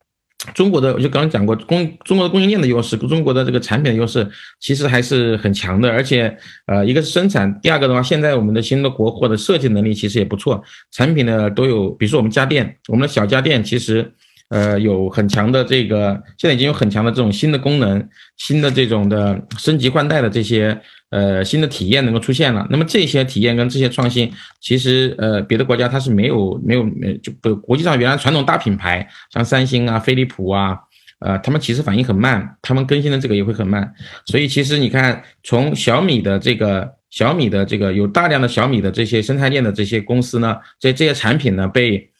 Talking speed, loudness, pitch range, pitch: 335 characters per minute, -16 LUFS, 105-135 Hz, 120 Hz